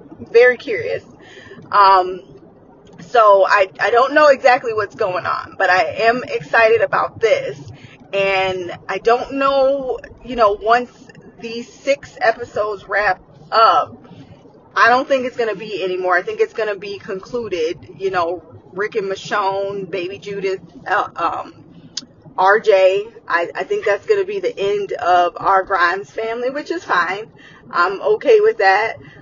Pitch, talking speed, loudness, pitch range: 225 Hz, 155 wpm, -17 LUFS, 195-285 Hz